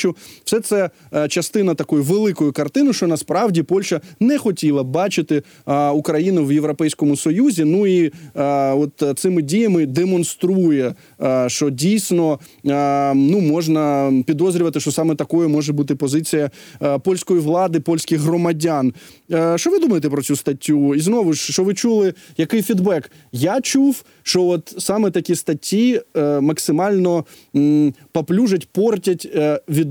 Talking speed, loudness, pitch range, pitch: 125 wpm, -18 LUFS, 150-185 Hz, 165 Hz